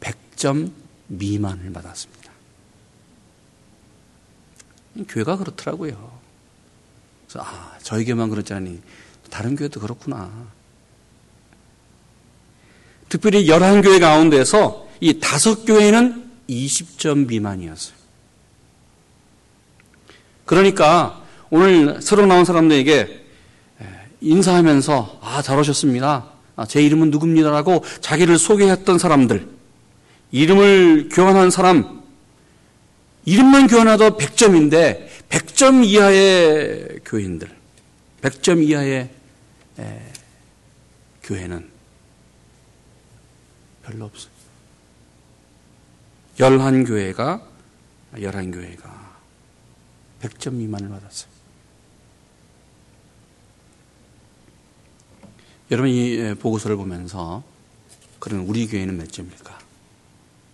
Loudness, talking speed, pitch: -15 LUFS, 185 characters per minute, 115 Hz